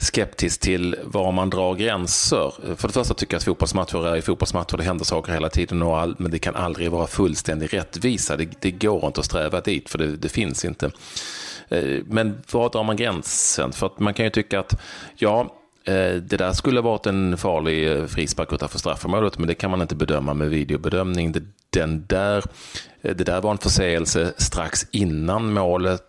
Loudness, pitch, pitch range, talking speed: -23 LUFS, 90 Hz, 80-100 Hz, 190 wpm